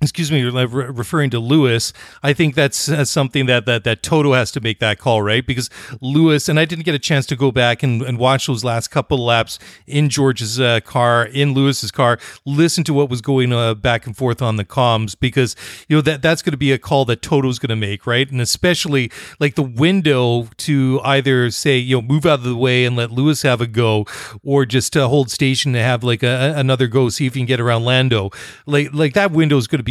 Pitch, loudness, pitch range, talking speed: 130 Hz, -16 LUFS, 120-145 Hz, 235 wpm